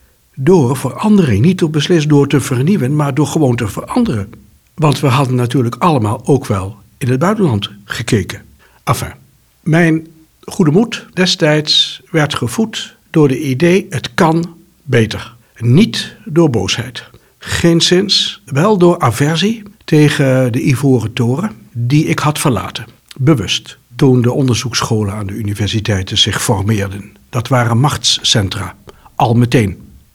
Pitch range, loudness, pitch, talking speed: 120-165 Hz, -13 LUFS, 140 Hz, 130 wpm